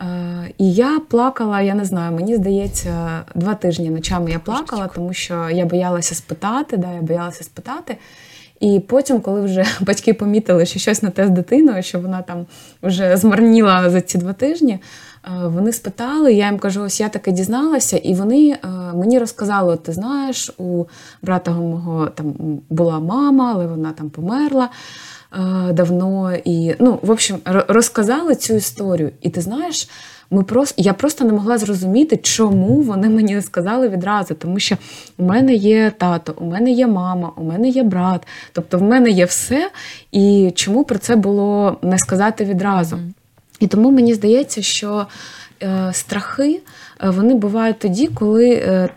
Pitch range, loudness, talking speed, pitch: 180-230 Hz, -16 LUFS, 160 wpm, 195 Hz